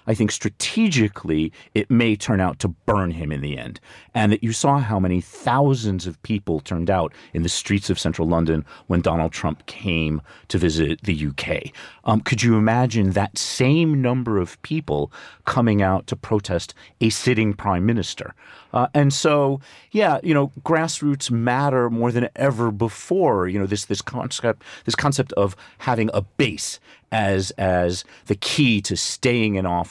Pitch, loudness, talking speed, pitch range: 105 Hz, -21 LUFS, 175 wpm, 90-125 Hz